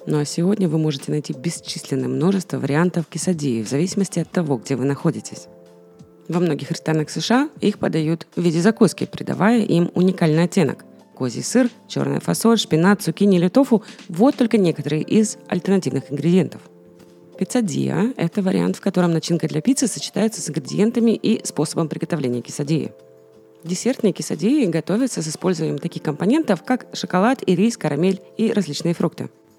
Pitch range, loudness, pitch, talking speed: 150-205 Hz, -20 LUFS, 170 Hz, 150 wpm